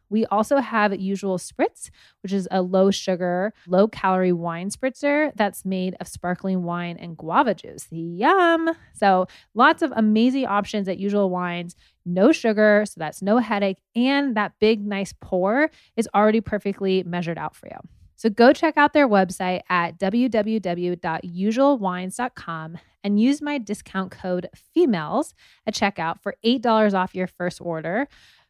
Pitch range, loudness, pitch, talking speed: 180-230 Hz, -22 LUFS, 200 Hz, 150 wpm